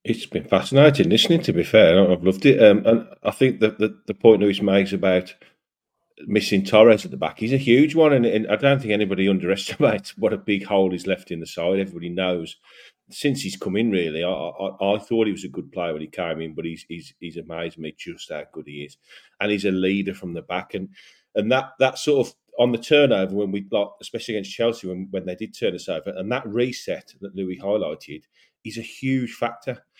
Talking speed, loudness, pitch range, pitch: 230 wpm, -21 LUFS, 95-115 Hz, 100 Hz